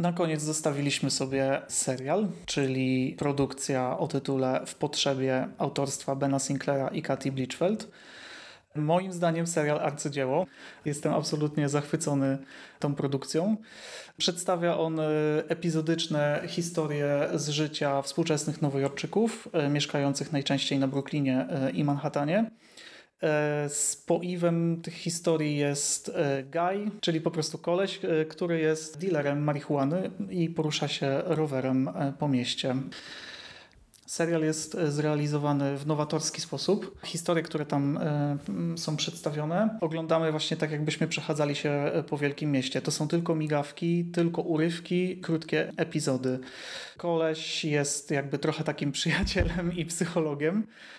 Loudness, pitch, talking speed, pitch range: -29 LUFS, 155 Hz, 110 wpm, 145-165 Hz